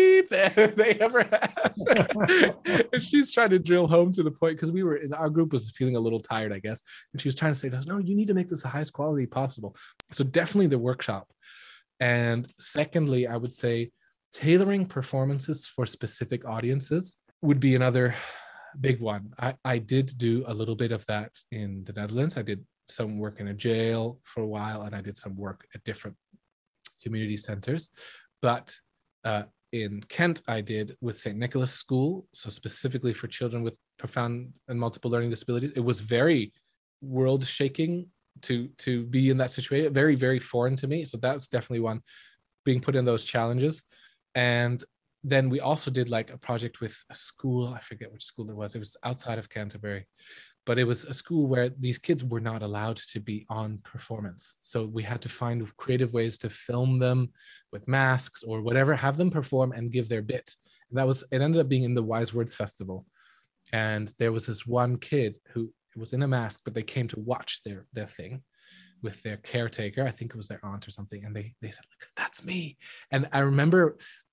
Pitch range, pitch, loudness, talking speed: 115-140 Hz, 125 Hz, -27 LUFS, 200 wpm